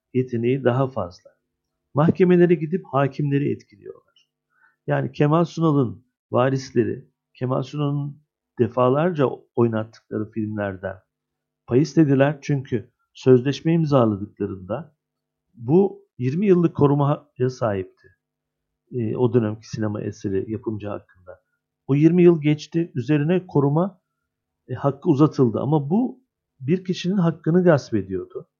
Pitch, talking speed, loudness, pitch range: 135 Hz, 100 wpm, -21 LUFS, 115-165 Hz